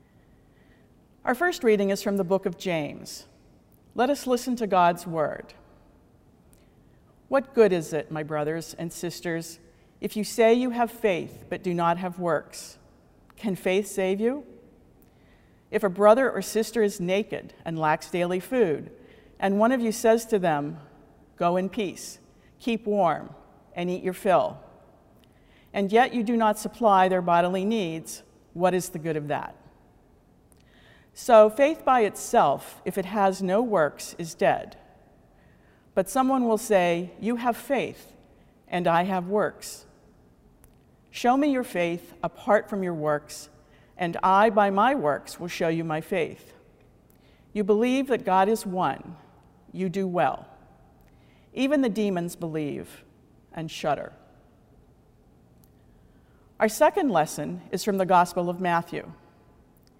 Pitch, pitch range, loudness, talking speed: 195 Hz, 170-220 Hz, -25 LUFS, 145 wpm